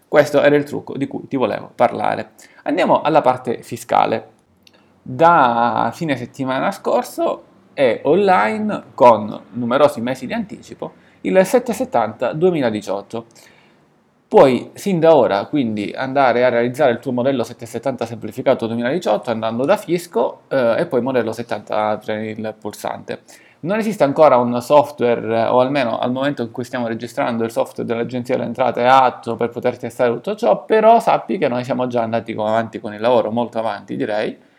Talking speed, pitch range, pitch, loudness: 160 wpm, 115-145 Hz, 125 Hz, -18 LUFS